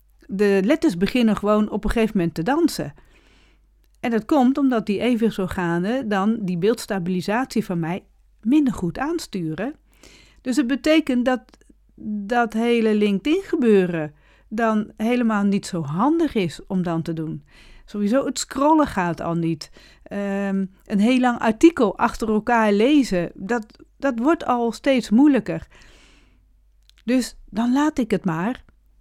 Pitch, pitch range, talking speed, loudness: 220 Hz, 190-255 Hz, 140 wpm, -21 LUFS